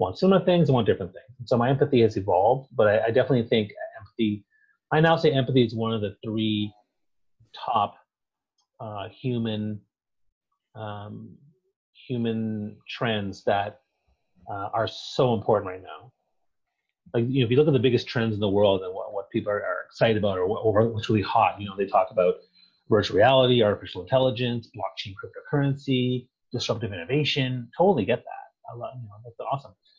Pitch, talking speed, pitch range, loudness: 120 Hz, 180 wpm, 105-130 Hz, -24 LUFS